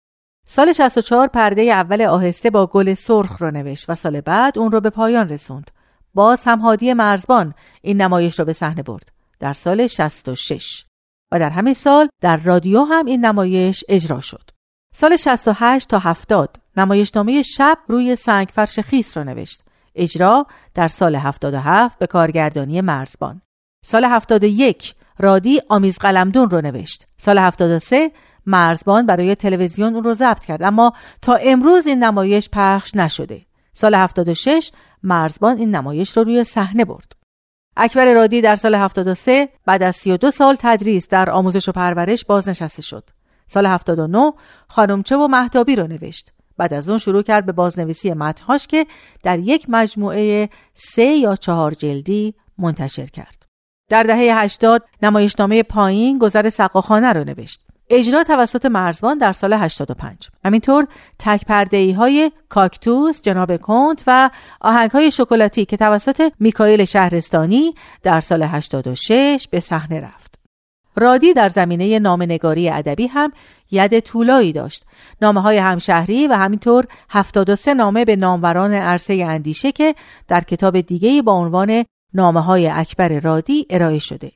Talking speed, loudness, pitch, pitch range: 145 wpm, -15 LUFS, 205 Hz, 175-235 Hz